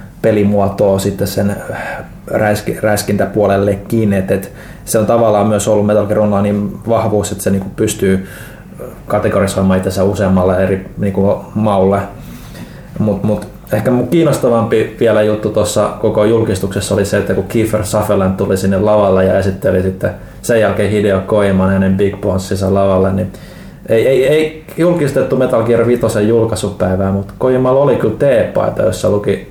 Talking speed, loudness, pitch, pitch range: 140 wpm, -13 LUFS, 105 Hz, 95-110 Hz